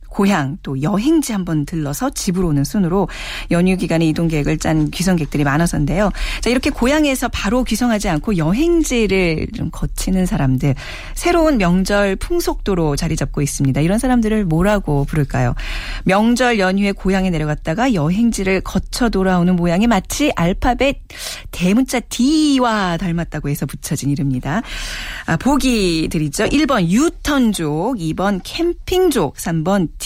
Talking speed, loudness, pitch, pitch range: 325 characters per minute, -17 LUFS, 190 Hz, 160-240 Hz